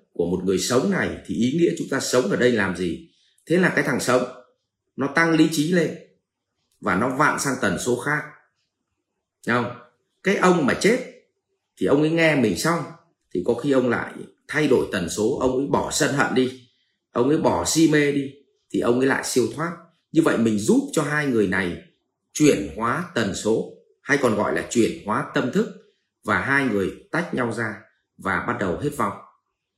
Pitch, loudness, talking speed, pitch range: 150 Hz, -22 LUFS, 205 wpm, 125-170 Hz